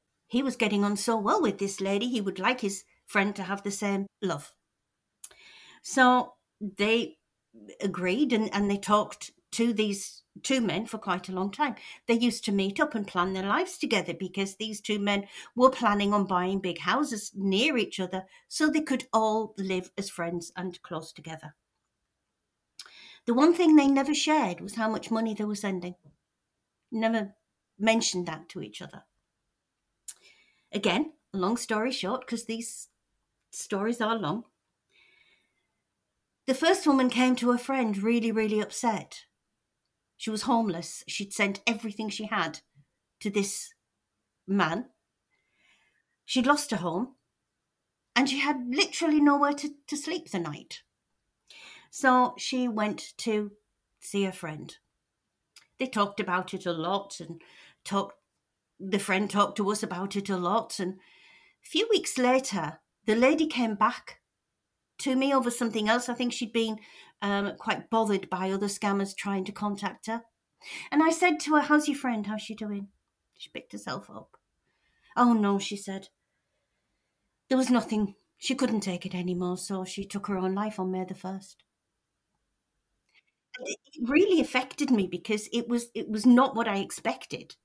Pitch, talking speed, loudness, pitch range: 215 Hz, 160 wpm, -28 LUFS, 195-250 Hz